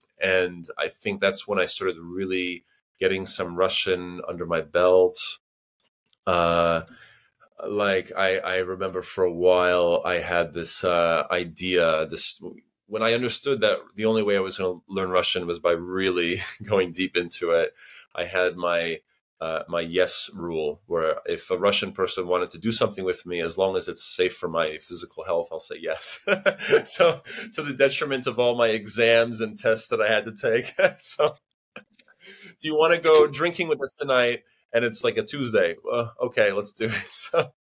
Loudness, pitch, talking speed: -24 LUFS, 95 Hz, 180 wpm